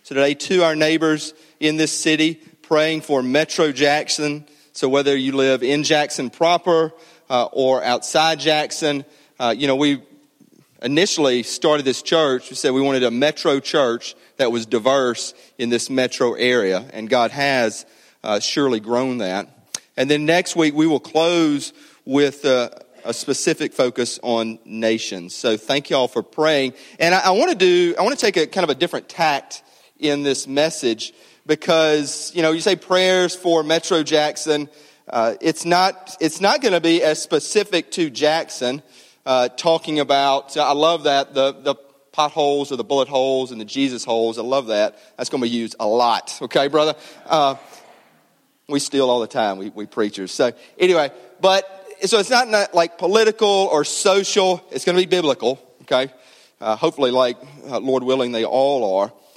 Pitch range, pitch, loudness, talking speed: 130-165 Hz, 150 Hz, -19 LUFS, 180 wpm